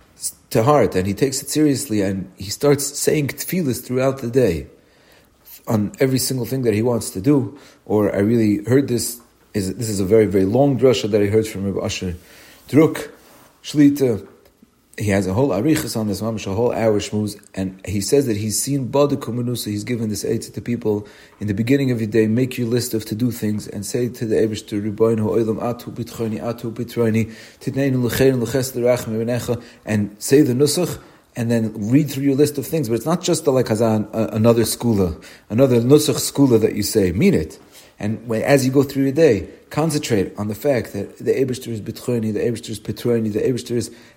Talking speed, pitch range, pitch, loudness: 195 wpm, 110-135 Hz, 115 Hz, -19 LUFS